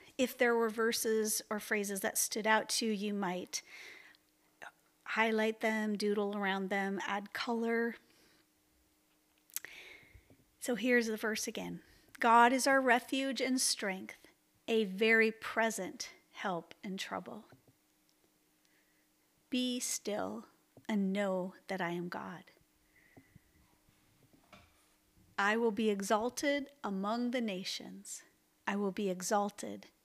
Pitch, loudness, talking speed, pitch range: 220 Hz, -34 LUFS, 110 wpm, 200-240 Hz